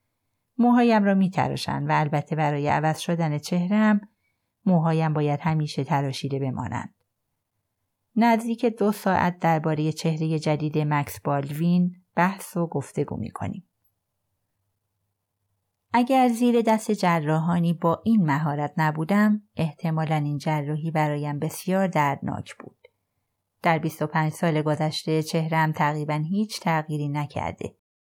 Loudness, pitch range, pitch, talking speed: -24 LUFS, 145-180 Hz, 155 Hz, 105 wpm